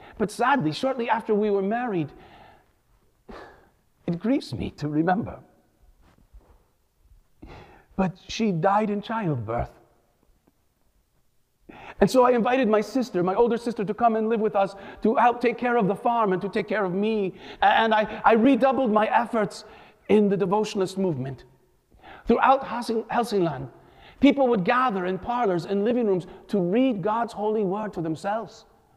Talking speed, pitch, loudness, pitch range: 150 wpm, 215 Hz, -24 LUFS, 195-235 Hz